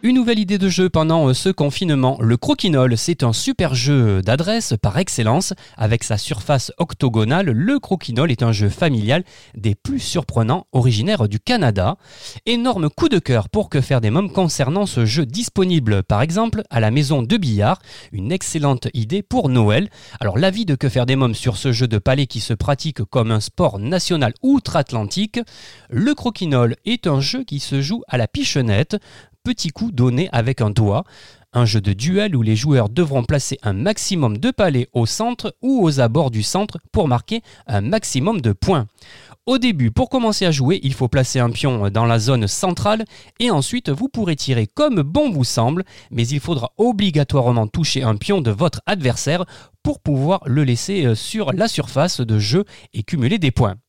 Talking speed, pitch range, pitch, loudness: 185 wpm, 120-185 Hz, 135 Hz, -18 LUFS